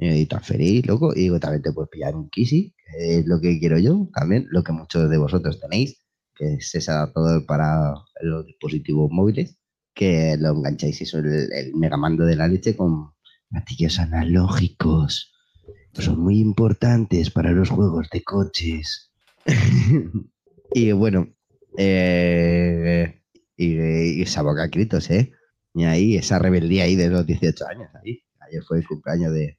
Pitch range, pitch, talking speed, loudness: 80-90 Hz, 85 Hz, 160 wpm, -21 LUFS